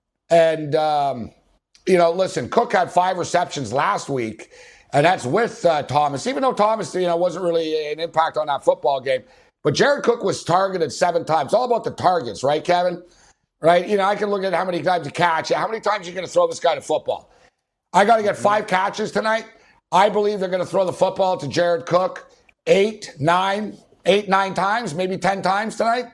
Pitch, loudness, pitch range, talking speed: 185 Hz, -20 LUFS, 170-210 Hz, 215 wpm